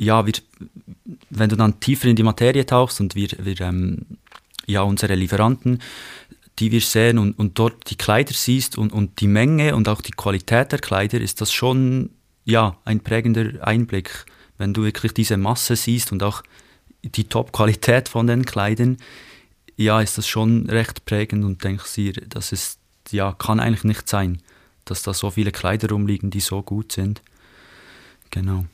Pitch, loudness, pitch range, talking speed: 110 Hz, -20 LUFS, 100-115 Hz, 175 wpm